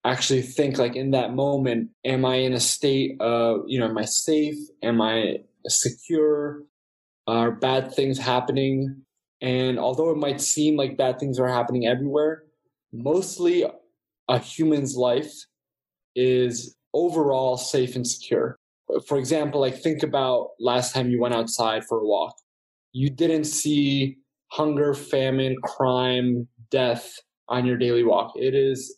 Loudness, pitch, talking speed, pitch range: -23 LUFS, 130 Hz, 145 wpm, 125-145 Hz